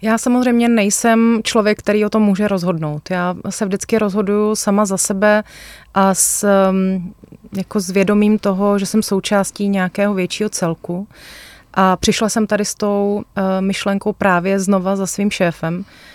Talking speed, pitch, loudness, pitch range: 150 wpm, 200 Hz, -16 LUFS, 190-210 Hz